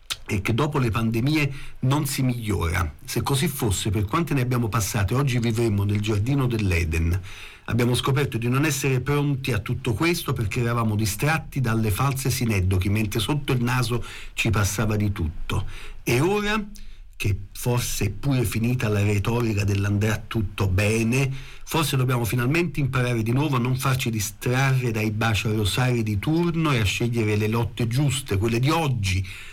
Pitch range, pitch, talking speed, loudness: 105-135 Hz, 120 Hz, 165 wpm, -24 LUFS